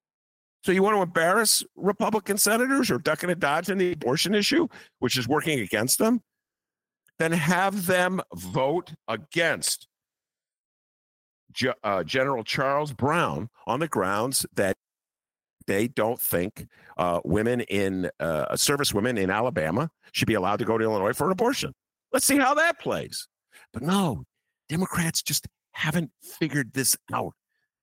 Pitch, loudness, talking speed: 155 Hz, -25 LUFS, 150 wpm